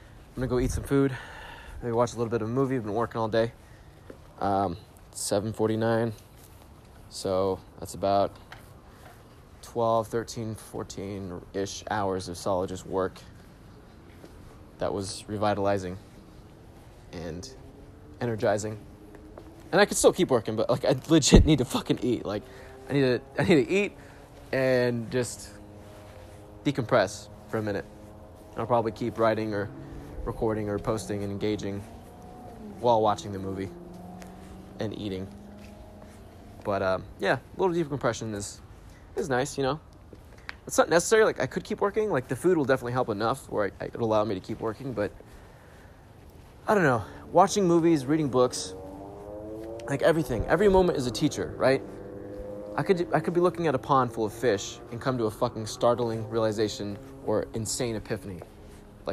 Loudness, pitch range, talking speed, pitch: -27 LUFS, 100-125 Hz, 160 wpm, 110 Hz